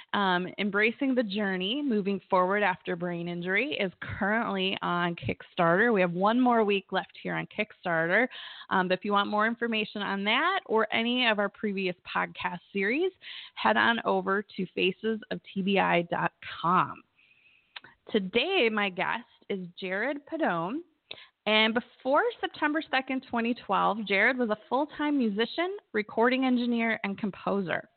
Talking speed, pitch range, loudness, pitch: 135 wpm, 190-245 Hz, -28 LUFS, 215 Hz